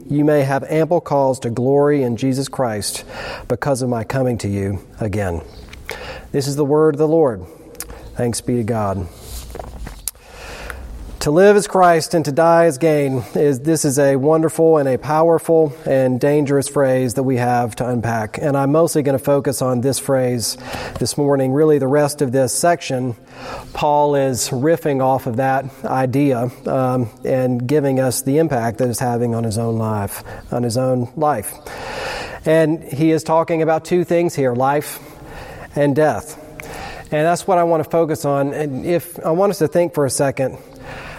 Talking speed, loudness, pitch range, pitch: 180 wpm, -17 LUFS, 125-155 Hz, 140 Hz